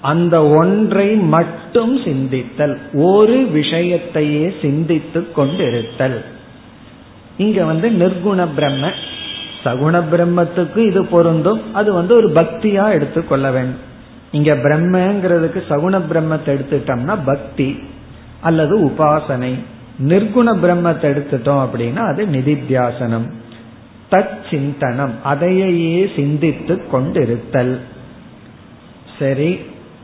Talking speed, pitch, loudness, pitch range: 75 wpm, 155 Hz, -15 LUFS, 135-180 Hz